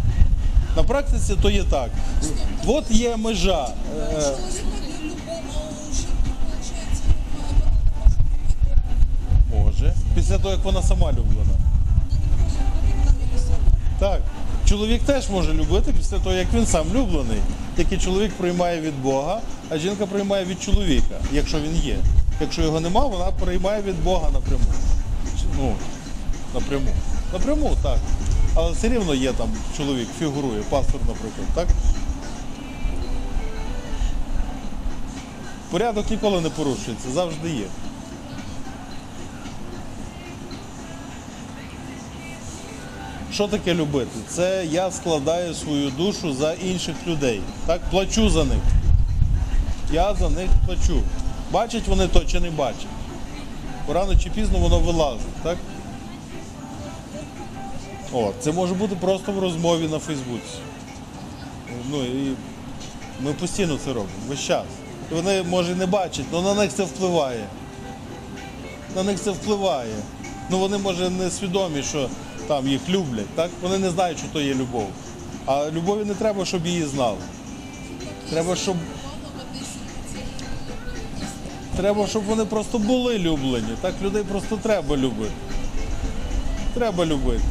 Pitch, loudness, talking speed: 155 Hz, -24 LUFS, 120 wpm